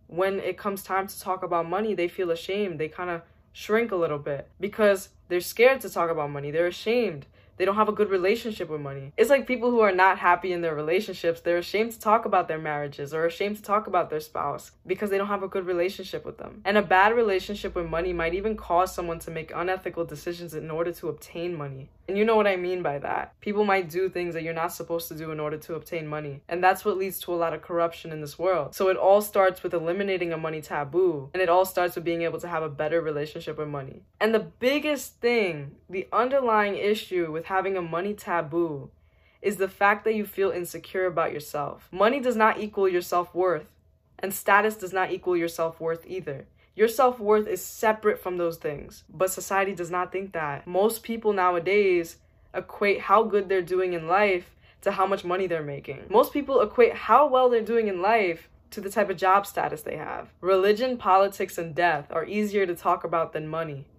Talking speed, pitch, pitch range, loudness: 225 wpm, 185 Hz, 165-200 Hz, -26 LUFS